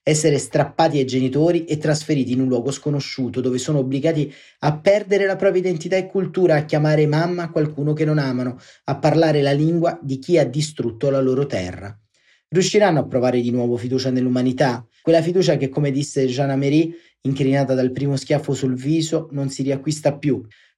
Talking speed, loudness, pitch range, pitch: 175 wpm, -20 LUFS, 130-160 Hz, 145 Hz